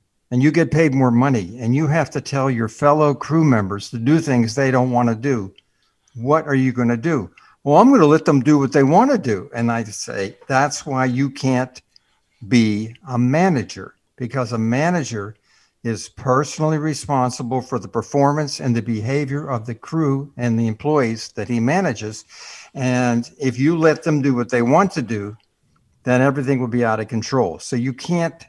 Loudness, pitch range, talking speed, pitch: -19 LUFS, 115-145 Hz, 195 wpm, 130 Hz